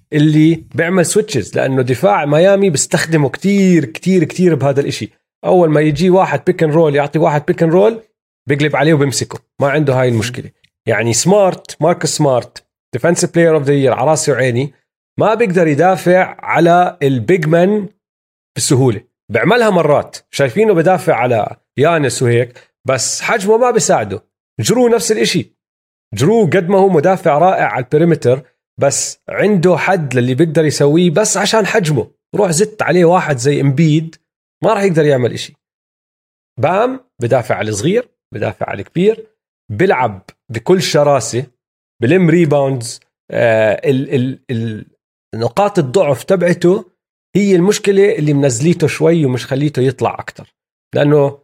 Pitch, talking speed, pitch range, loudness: 160 Hz, 135 wpm, 140-185 Hz, -13 LUFS